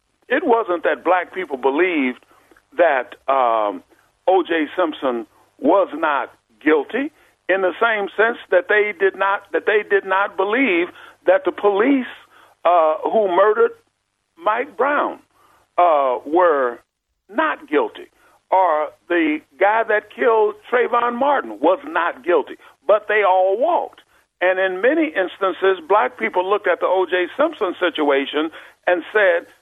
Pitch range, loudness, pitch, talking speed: 185-285 Hz, -19 LUFS, 210 Hz, 135 wpm